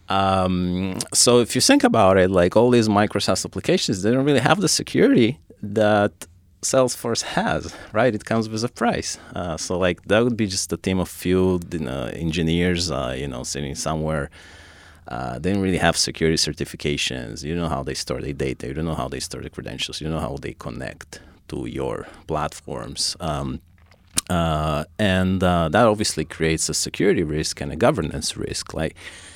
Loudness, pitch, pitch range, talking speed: -21 LUFS, 90 Hz, 80-105 Hz, 190 wpm